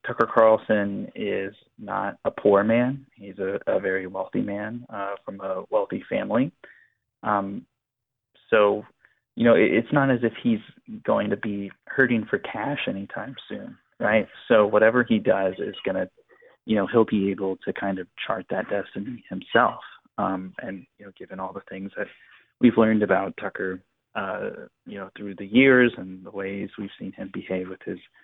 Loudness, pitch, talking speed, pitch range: -24 LUFS, 100 Hz, 180 wpm, 95-120 Hz